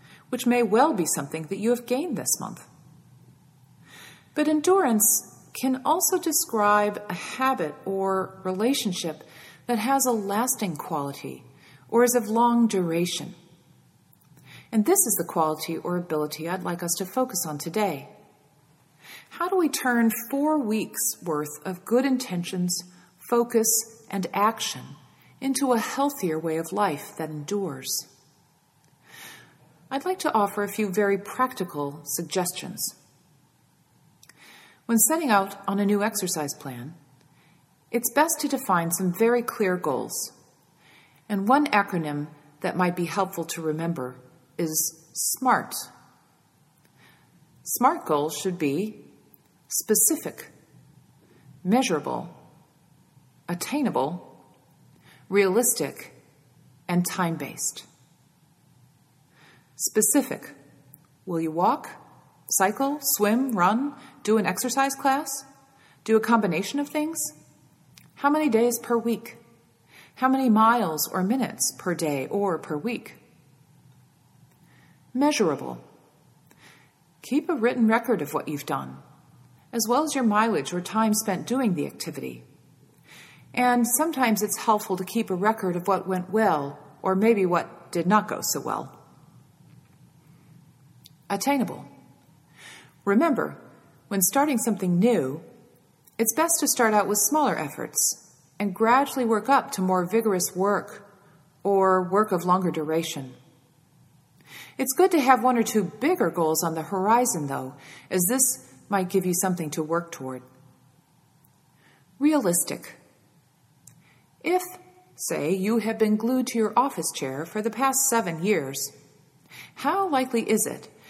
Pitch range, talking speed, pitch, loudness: 155-235 Hz, 125 wpm, 195 Hz, -25 LUFS